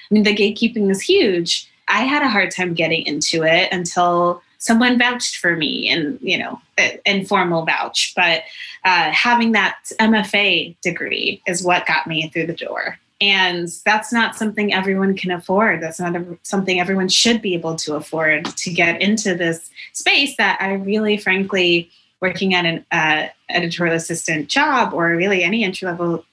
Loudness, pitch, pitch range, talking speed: -17 LUFS, 185 Hz, 170-205 Hz, 170 wpm